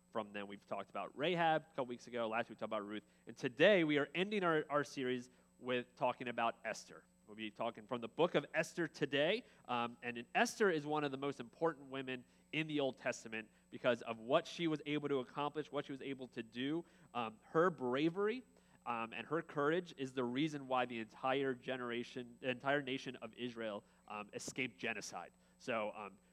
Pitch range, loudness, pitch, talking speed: 120-150 Hz, -40 LUFS, 135 Hz, 205 wpm